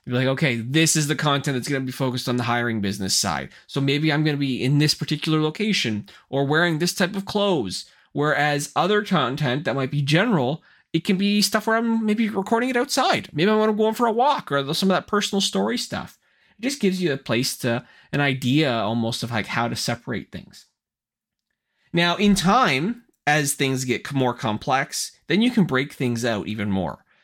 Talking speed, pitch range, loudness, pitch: 215 wpm, 130-200 Hz, -22 LUFS, 150 Hz